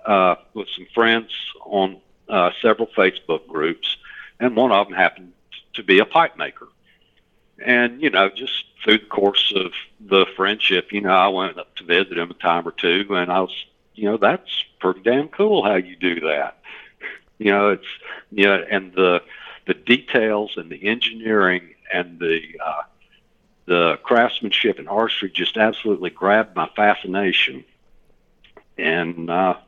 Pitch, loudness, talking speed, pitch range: 100 Hz, -19 LUFS, 160 wpm, 90-110 Hz